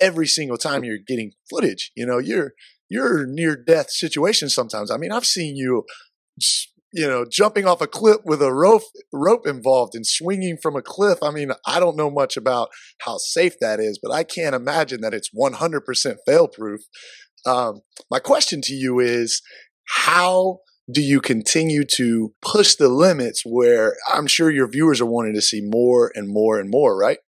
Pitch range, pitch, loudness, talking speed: 125-190 Hz, 150 Hz, -19 LUFS, 185 wpm